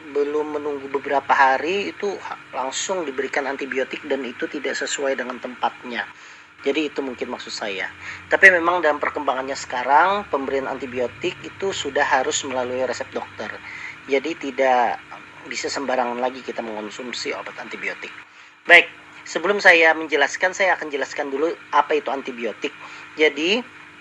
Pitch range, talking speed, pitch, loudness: 130-160 Hz, 130 wpm, 140 Hz, -21 LUFS